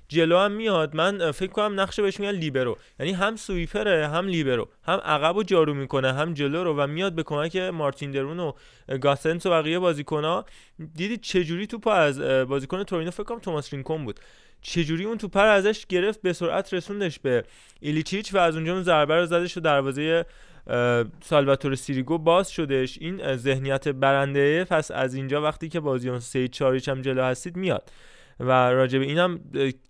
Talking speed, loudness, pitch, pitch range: 175 wpm, -24 LUFS, 160 Hz, 140-185 Hz